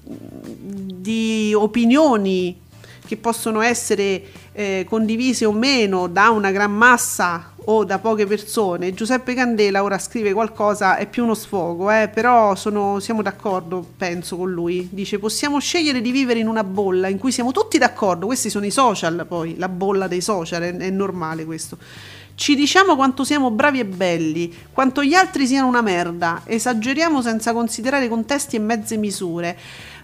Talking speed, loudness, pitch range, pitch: 160 wpm, -19 LUFS, 190-245 Hz, 215 Hz